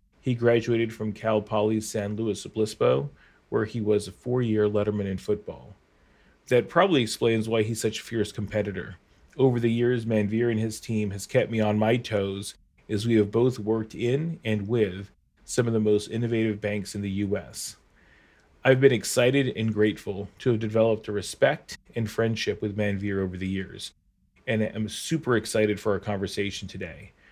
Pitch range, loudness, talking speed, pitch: 105-115 Hz, -26 LUFS, 175 wpm, 110 Hz